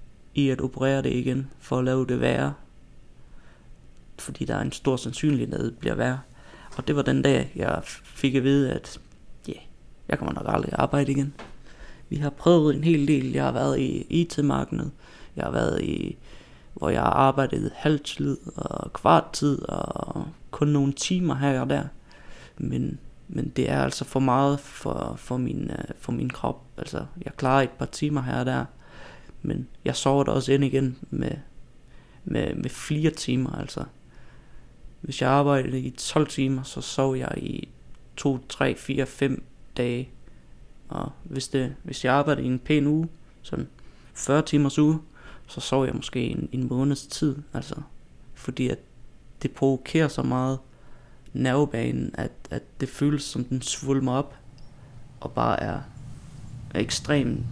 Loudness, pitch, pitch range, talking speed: -26 LUFS, 135 Hz, 130-145 Hz, 165 wpm